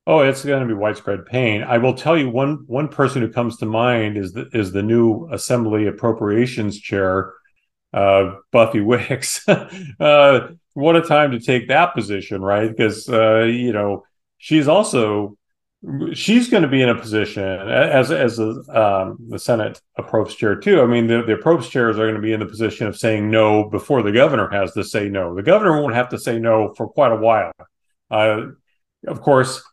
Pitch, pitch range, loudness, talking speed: 115 Hz, 105-135 Hz, -17 LUFS, 195 wpm